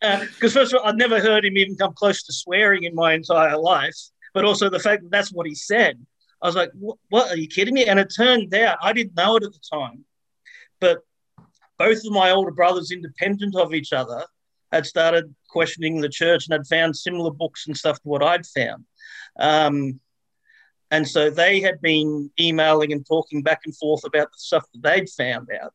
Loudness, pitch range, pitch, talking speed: -20 LUFS, 155-205 Hz, 175 Hz, 215 wpm